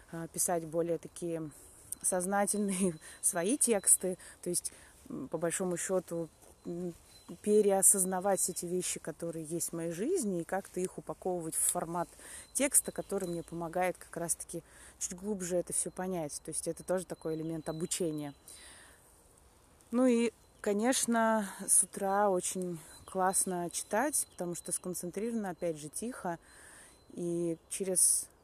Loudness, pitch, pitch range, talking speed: -32 LUFS, 180 Hz, 170-195 Hz, 125 wpm